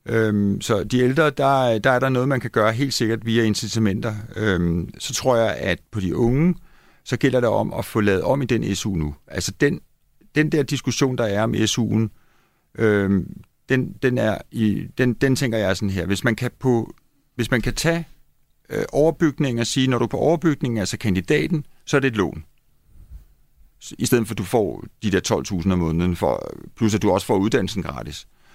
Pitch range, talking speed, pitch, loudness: 105-135 Hz, 210 wpm, 115 Hz, -21 LUFS